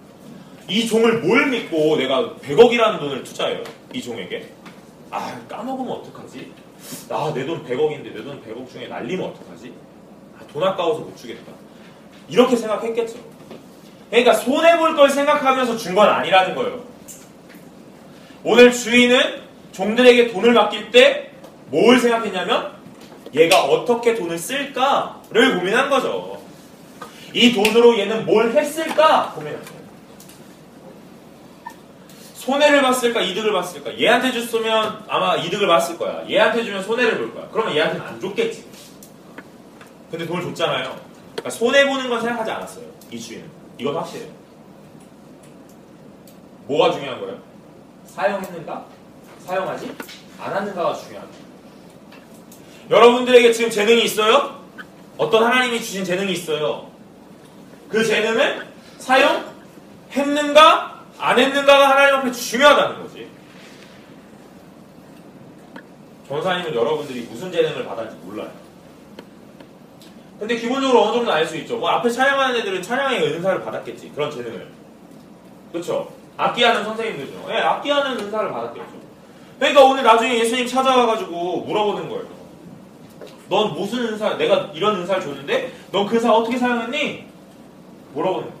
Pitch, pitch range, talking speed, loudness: 235 Hz, 215-270 Hz, 305 characters per minute, -18 LUFS